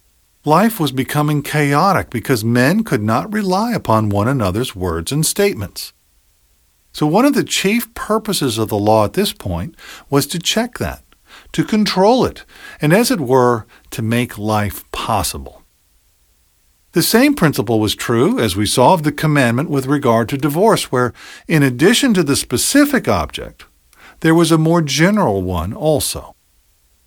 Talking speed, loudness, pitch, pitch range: 155 wpm, -15 LUFS, 140 Hz, 110-180 Hz